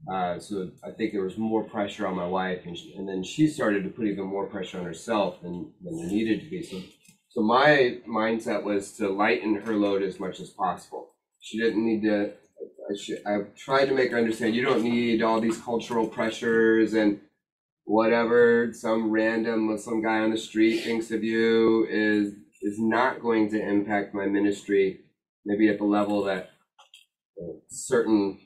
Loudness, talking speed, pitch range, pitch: -26 LUFS, 190 wpm, 100-115 Hz, 110 Hz